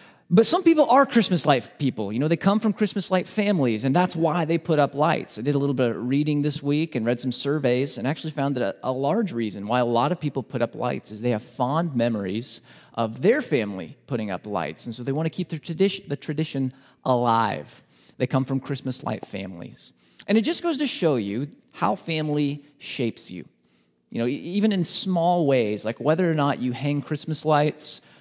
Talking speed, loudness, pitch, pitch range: 225 wpm, -23 LUFS, 145 Hz, 125-165 Hz